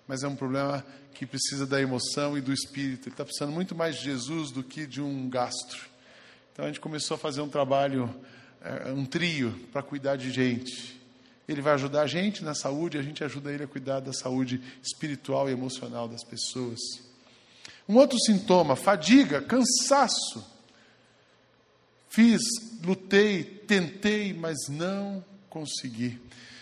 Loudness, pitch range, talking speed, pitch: -28 LUFS, 130-170 Hz, 155 wpm, 140 Hz